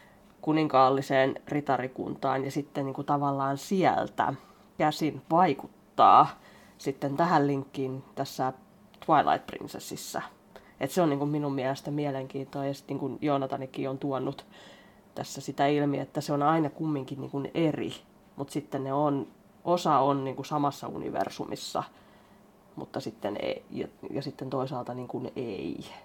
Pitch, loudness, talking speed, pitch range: 140 Hz, -29 LUFS, 135 wpm, 135-150 Hz